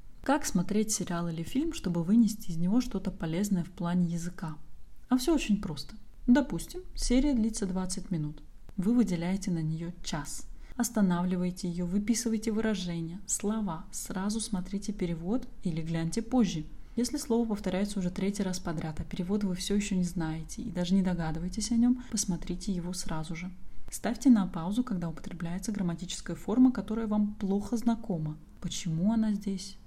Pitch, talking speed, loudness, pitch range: 195 Hz, 155 wpm, -31 LUFS, 175-220 Hz